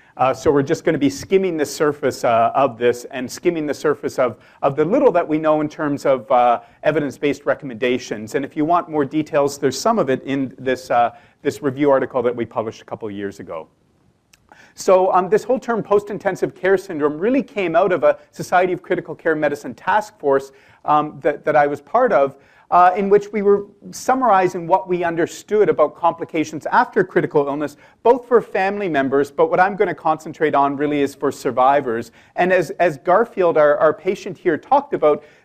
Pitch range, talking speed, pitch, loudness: 140-185 Hz, 205 wpm, 155 Hz, -18 LUFS